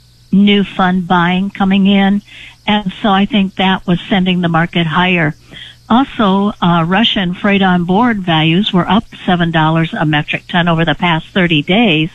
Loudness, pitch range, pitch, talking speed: -12 LUFS, 170-200 Hz, 185 Hz, 165 wpm